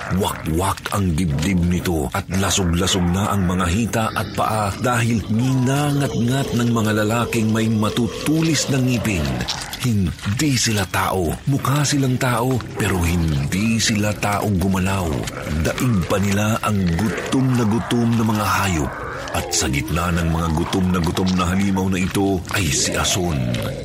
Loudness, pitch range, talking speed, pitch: -19 LUFS, 95-115 Hz, 145 wpm, 105 Hz